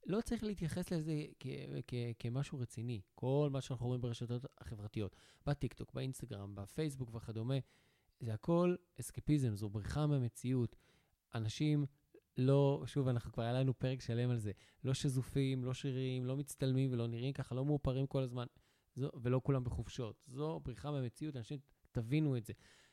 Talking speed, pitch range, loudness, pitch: 155 wpm, 120-140 Hz, -40 LUFS, 130 Hz